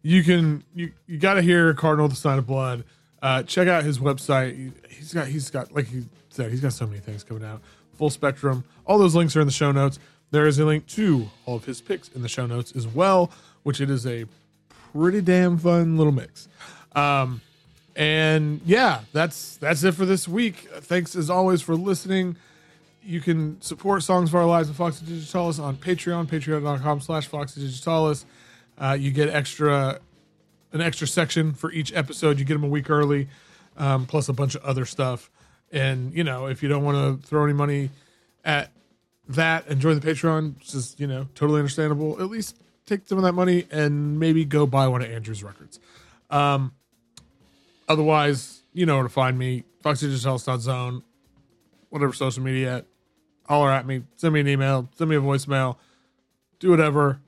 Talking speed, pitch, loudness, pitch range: 190 wpm, 150 Hz, -23 LUFS, 135-165 Hz